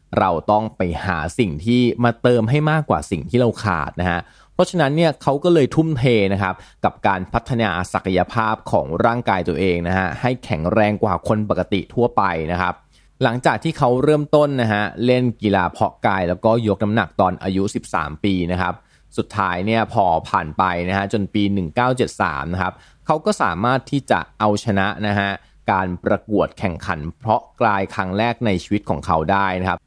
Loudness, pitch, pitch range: -19 LUFS, 105 Hz, 90-120 Hz